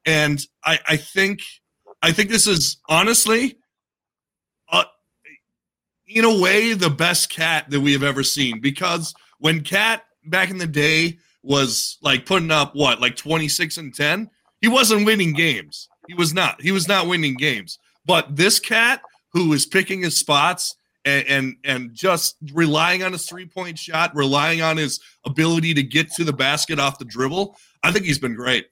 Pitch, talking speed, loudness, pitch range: 165 Hz, 180 wpm, -18 LUFS, 145-185 Hz